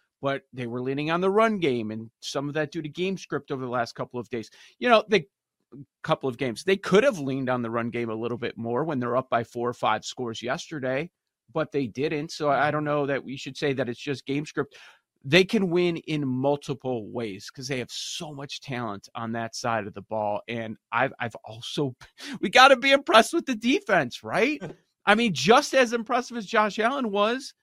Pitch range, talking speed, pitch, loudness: 120-190 Hz, 230 wpm, 140 Hz, -25 LUFS